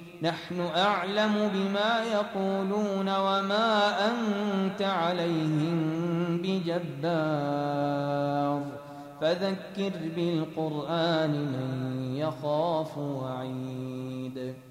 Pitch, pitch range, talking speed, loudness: 165 Hz, 145-195 Hz, 55 wpm, -29 LUFS